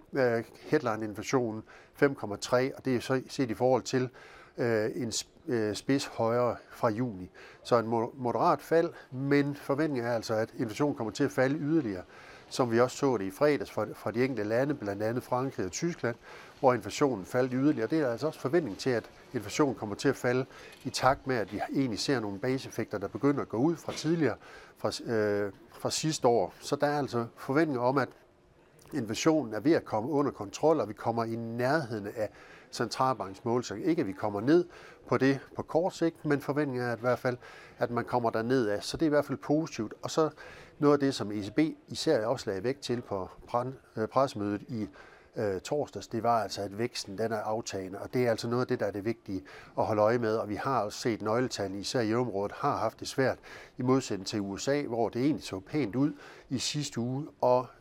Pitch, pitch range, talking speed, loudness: 125 Hz, 110-140 Hz, 210 wpm, -31 LUFS